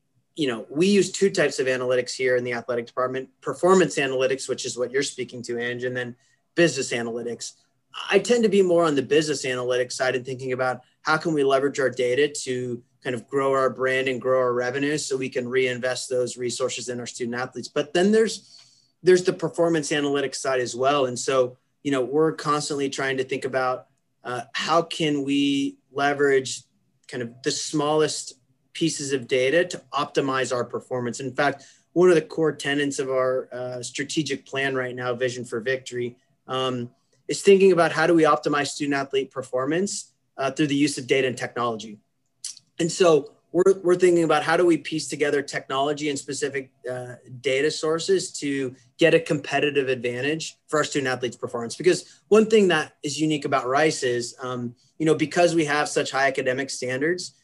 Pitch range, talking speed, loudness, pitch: 125-155 Hz, 190 wpm, -23 LUFS, 135 Hz